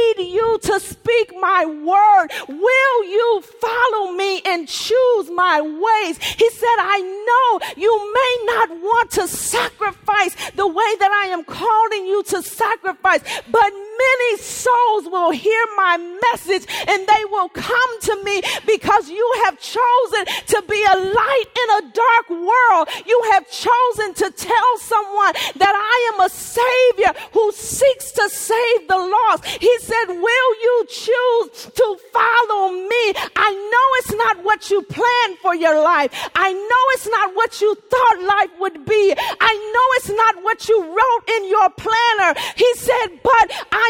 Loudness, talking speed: -16 LUFS, 160 wpm